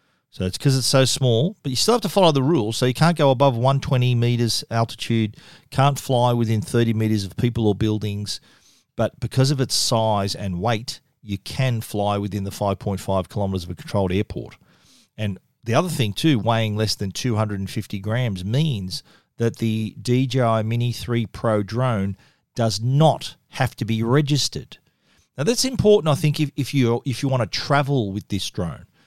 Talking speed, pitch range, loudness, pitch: 185 wpm, 105-135 Hz, -21 LUFS, 115 Hz